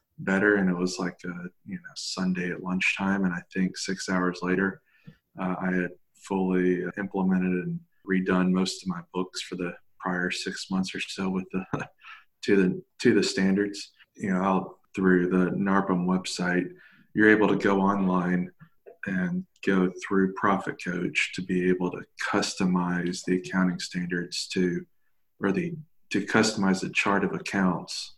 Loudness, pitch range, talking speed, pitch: -27 LUFS, 90-95 Hz, 160 wpm, 95 Hz